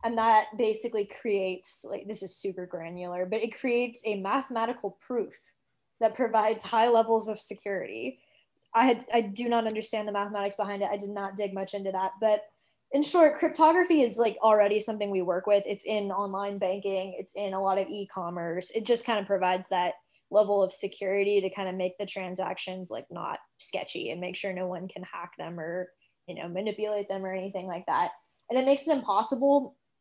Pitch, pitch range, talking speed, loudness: 205 Hz, 190-225 Hz, 200 wpm, -28 LUFS